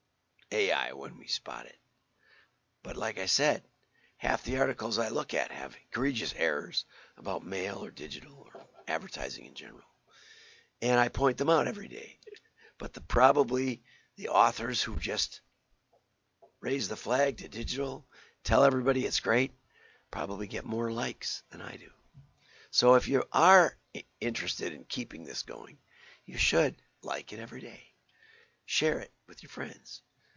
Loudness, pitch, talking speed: -30 LUFS, 130 Hz, 150 wpm